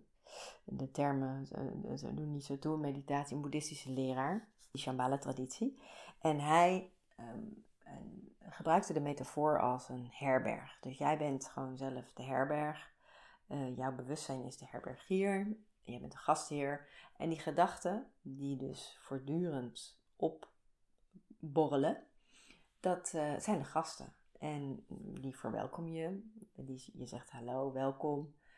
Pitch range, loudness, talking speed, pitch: 135-175 Hz, -39 LUFS, 130 wpm, 145 Hz